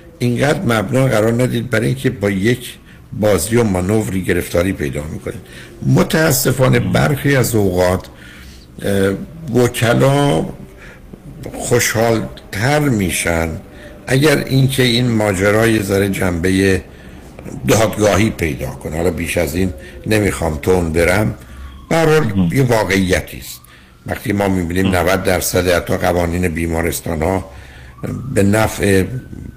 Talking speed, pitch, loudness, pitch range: 110 wpm, 100 Hz, -15 LUFS, 85-120 Hz